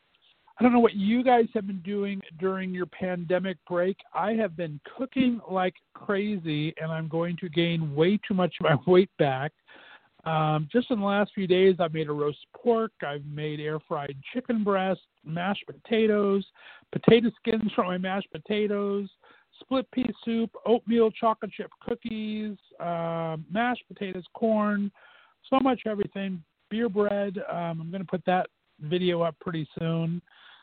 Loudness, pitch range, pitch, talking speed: -27 LUFS, 170-220 Hz, 195 Hz, 165 wpm